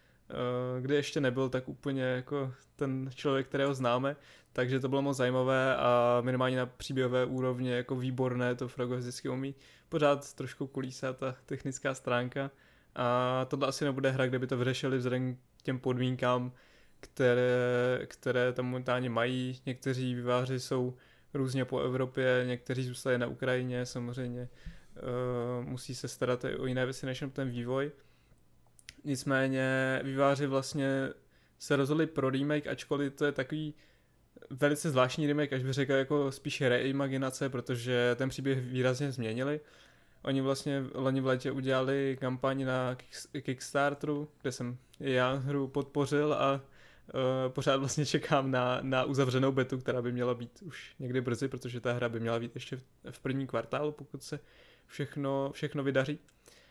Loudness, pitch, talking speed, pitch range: -33 LUFS, 130 Hz, 150 wpm, 125-140 Hz